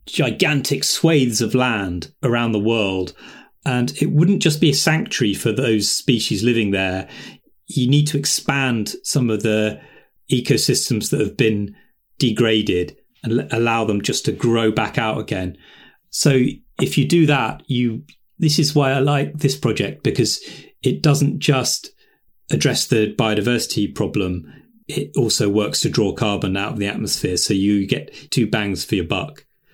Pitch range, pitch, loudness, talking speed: 105-145 Hz, 125 Hz, -19 LUFS, 160 wpm